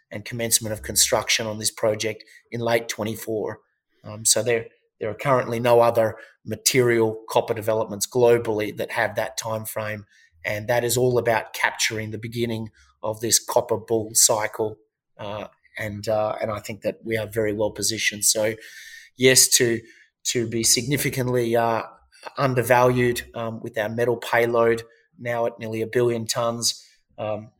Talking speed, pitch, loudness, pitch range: 155 wpm, 115 Hz, -22 LUFS, 110-120 Hz